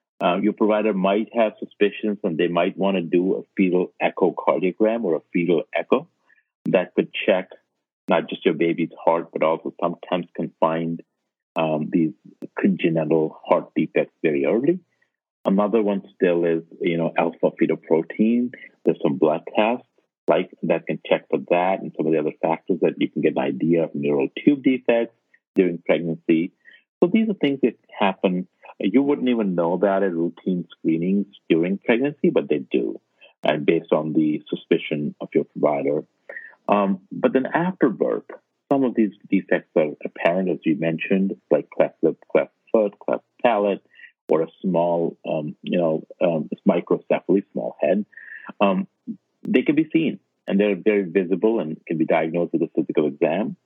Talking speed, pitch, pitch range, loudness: 170 wpm, 100 Hz, 85-120 Hz, -22 LUFS